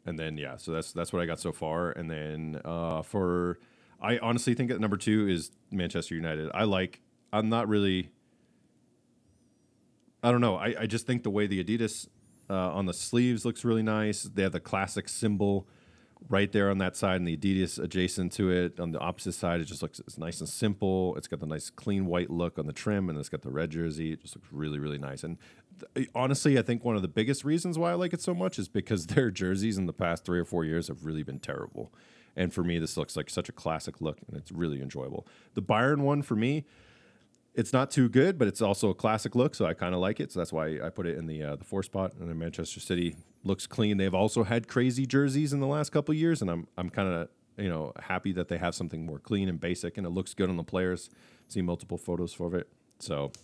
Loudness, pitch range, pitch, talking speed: -31 LUFS, 85-110 Hz, 95 Hz, 245 wpm